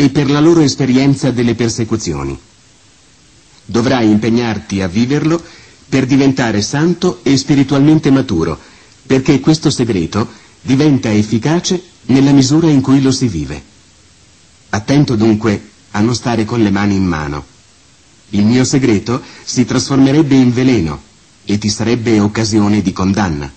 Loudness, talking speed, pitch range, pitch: -13 LUFS, 130 wpm, 105-135 Hz, 120 Hz